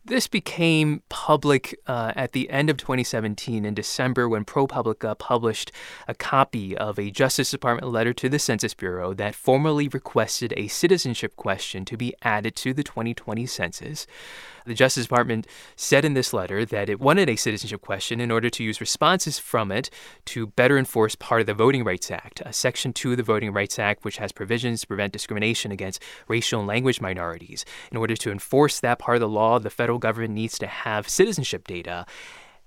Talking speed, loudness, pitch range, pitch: 190 wpm, -24 LUFS, 110-130 Hz, 120 Hz